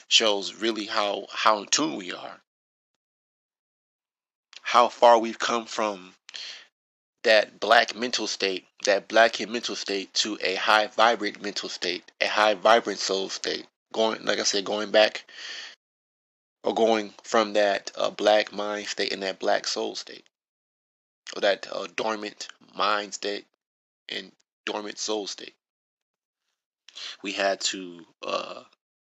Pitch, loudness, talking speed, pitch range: 105 Hz, -25 LUFS, 135 wpm, 100-110 Hz